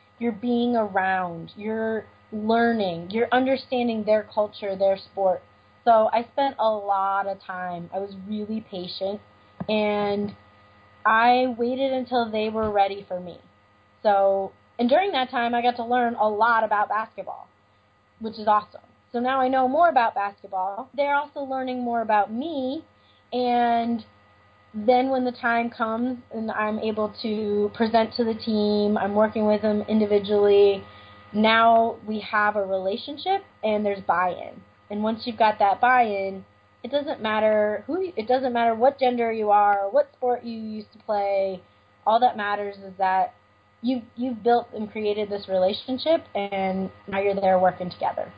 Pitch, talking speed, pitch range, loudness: 215 Hz, 160 wpm, 195-240 Hz, -24 LUFS